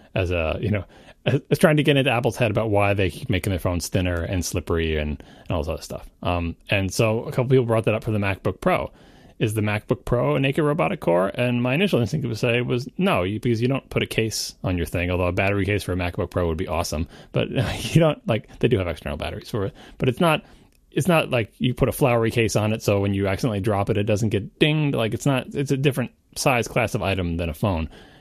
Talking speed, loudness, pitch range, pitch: 265 wpm, -23 LUFS, 90-125 Hz, 110 Hz